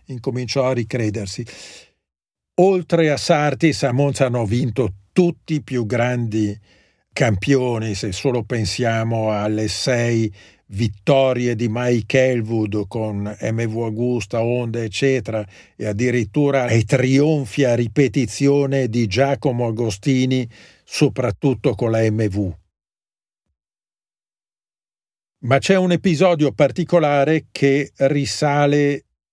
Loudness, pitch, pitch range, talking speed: -19 LUFS, 125 Hz, 110-140 Hz, 100 wpm